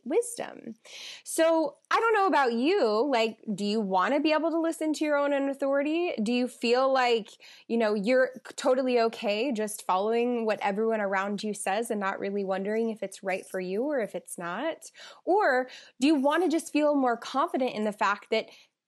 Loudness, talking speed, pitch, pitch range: -27 LUFS, 195 wpm, 240 Hz, 210-295 Hz